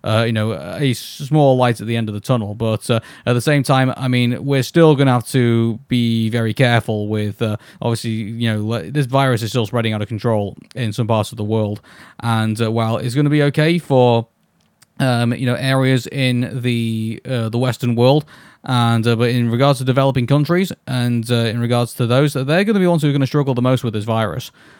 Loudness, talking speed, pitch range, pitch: -17 LUFS, 230 wpm, 115-135 Hz, 120 Hz